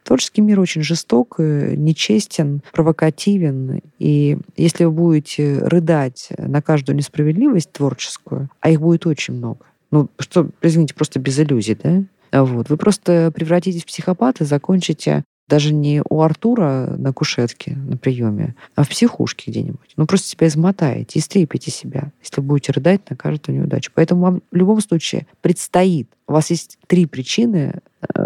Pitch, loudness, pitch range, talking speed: 160 Hz, -17 LUFS, 145-175 Hz, 150 wpm